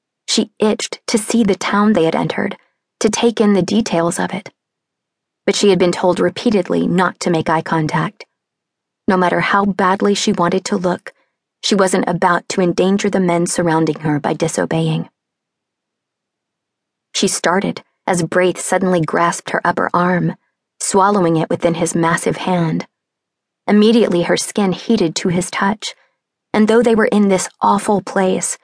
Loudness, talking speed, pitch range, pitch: -16 LUFS, 160 wpm, 170-205 Hz, 185 Hz